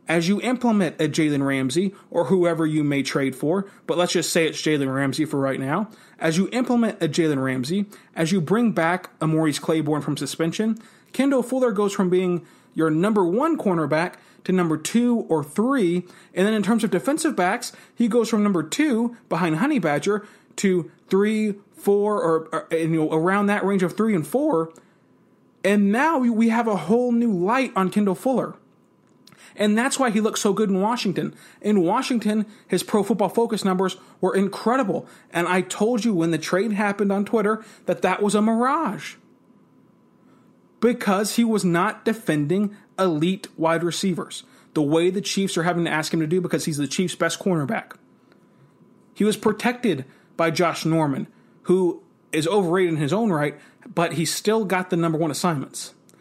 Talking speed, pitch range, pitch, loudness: 180 wpm, 165-215 Hz, 190 Hz, -22 LUFS